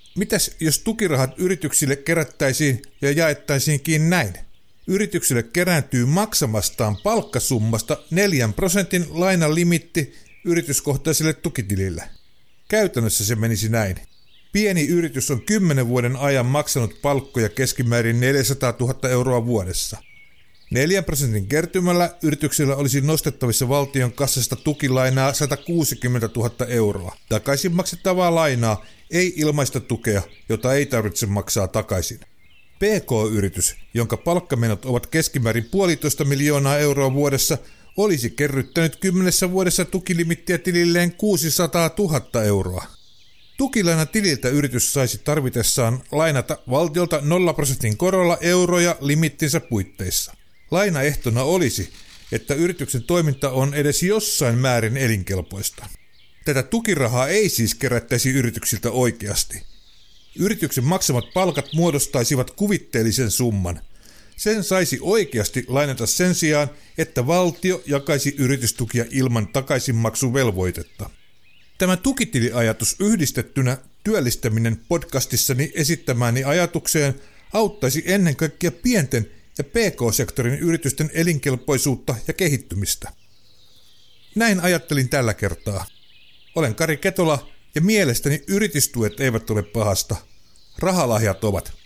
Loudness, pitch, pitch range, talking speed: -20 LUFS, 140 Hz, 115-170 Hz, 100 wpm